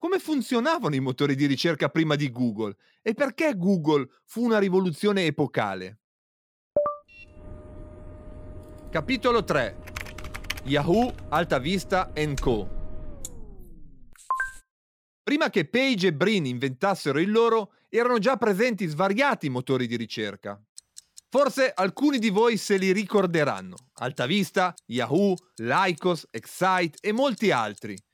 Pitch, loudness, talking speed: 180 Hz, -25 LUFS, 110 wpm